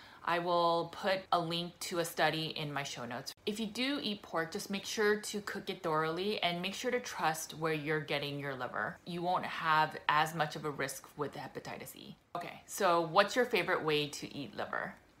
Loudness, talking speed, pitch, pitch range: -35 LUFS, 215 wpm, 170 Hz, 155-195 Hz